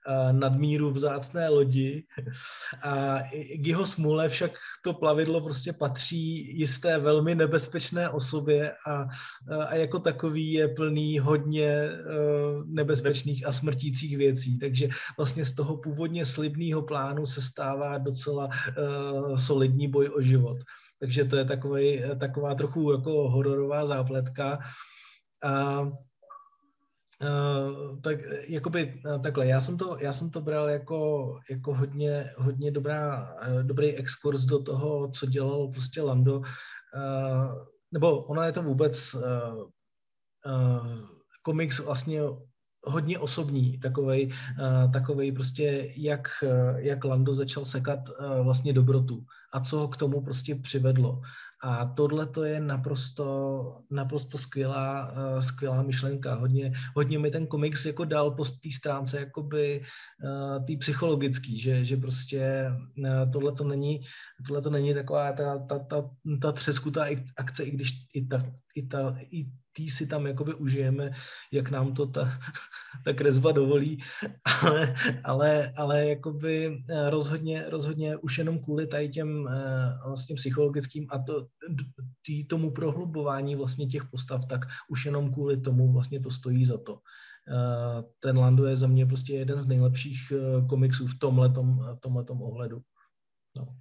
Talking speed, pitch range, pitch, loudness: 140 wpm, 130-150 Hz, 140 Hz, -29 LUFS